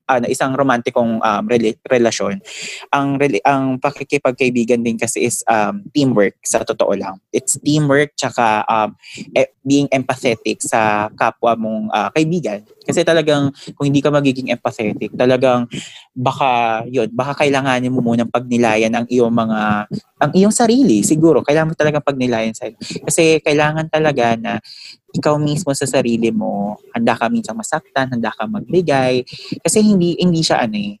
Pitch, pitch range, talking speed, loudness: 130 Hz, 115-150 Hz, 155 wpm, -16 LUFS